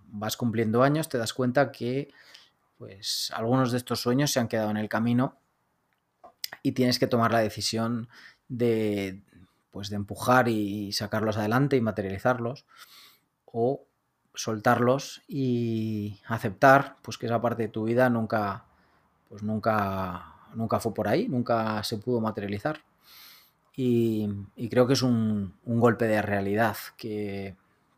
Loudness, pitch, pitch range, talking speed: -27 LUFS, 115 Hz, 105-125 Hz, 140 wpm